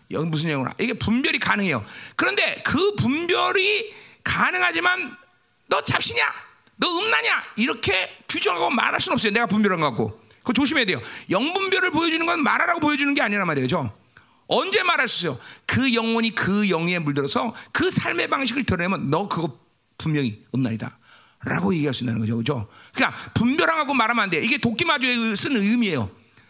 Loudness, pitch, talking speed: -21 LUFS, 225 Hz, 375 characters per minute